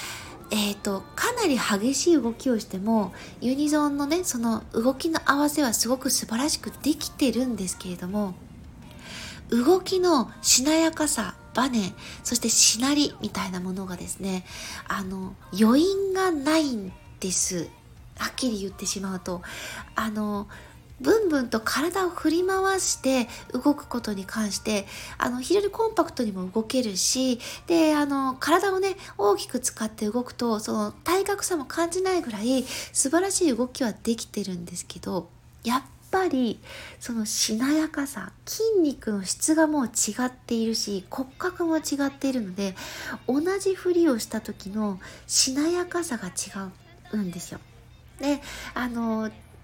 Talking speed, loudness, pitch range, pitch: 290 characters per minute, -25 LUFS, 210-315 Hz, 250 Hz